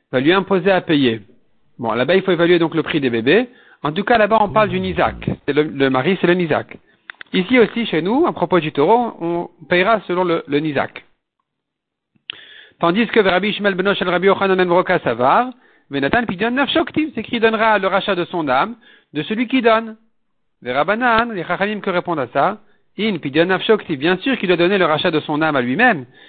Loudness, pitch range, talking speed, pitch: -17 LUFS, 170-225 Hz, 210 wpm, 190 Hz